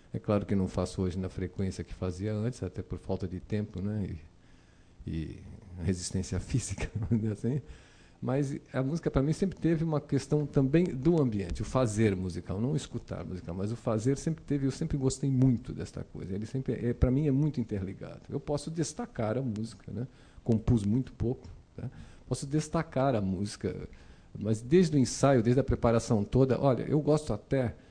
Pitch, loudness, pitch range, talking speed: 115 Hz, -31 LUFS, 95-140 Hz, 185 wpm